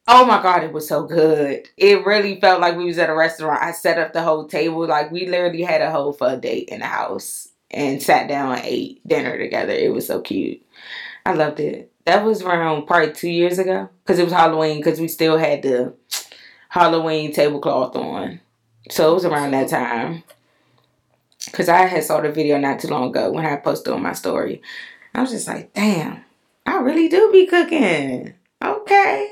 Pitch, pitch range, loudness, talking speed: 165 Hz, 155-200 Hz, -18 LUFS, 205 wpm